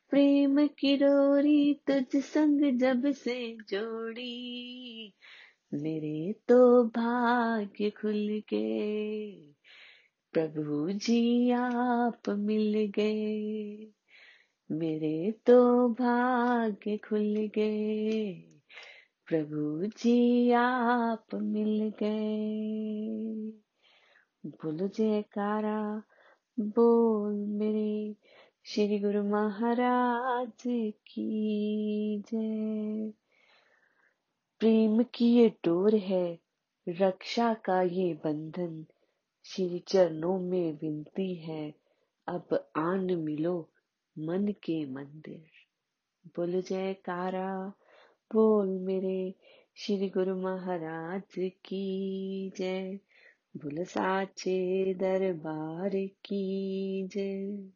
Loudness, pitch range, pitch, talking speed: -30 LUFS, 185-230 Hz, 210 Hz, 70 wpm